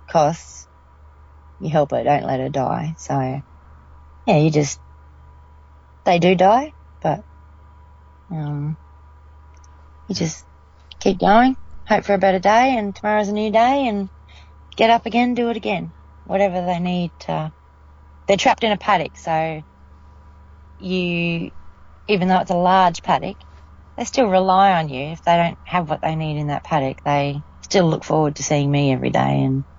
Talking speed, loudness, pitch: 160 wpm, -19 LUFS, 145 Hz